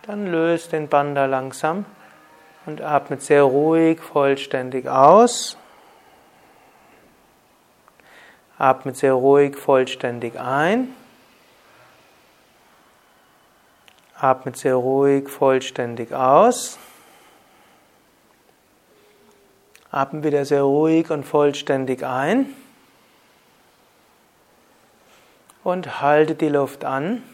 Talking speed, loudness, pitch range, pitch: 70 wpm, -19 LUFS, 135-165 Hz, 145 Hz